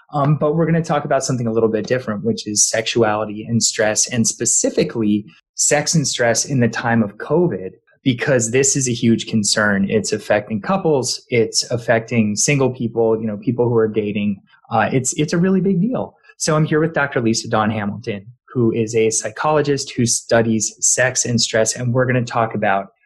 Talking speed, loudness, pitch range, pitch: 200 wpm, -17 LUFS, 110-135 Hz, 115 Hz